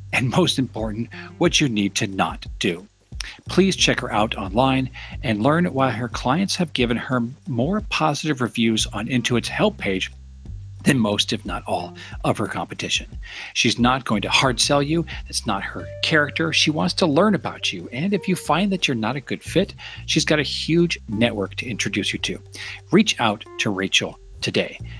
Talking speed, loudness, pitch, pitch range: 185 wpm, -21 LUFS, 120 Hz, 100-150 Hz